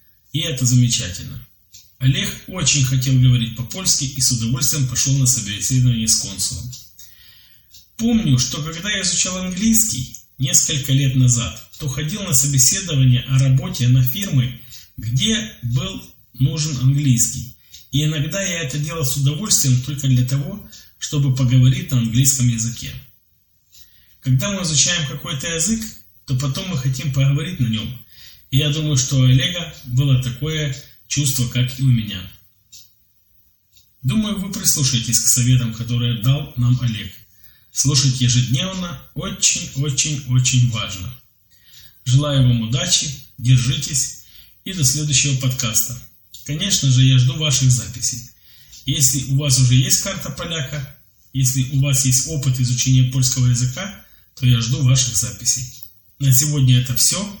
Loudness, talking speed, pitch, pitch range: -17 LUFS, 135 wpm, 130 Hz, 120-145 Hz